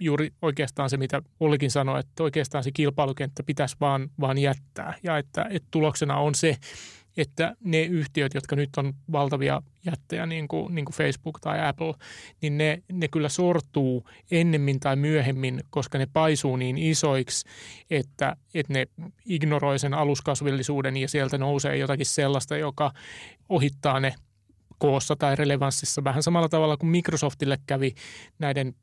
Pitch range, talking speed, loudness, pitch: 140-155 Hz, 150 wpm, -26 LUFS, 145 Hz